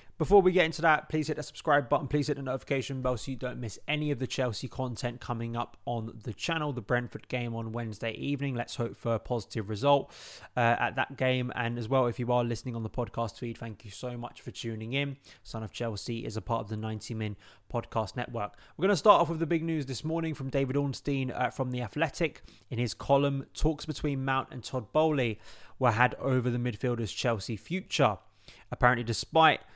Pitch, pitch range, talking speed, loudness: 125 Hz, 115-140 Hz, 225 wpm, -30 LUFS